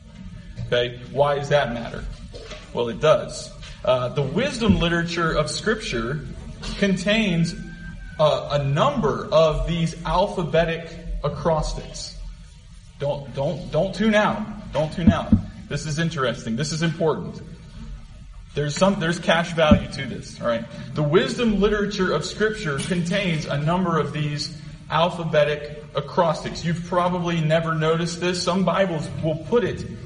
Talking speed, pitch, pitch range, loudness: 135 wpm, 165 Hz, 150-185 Hz, -22 LUFS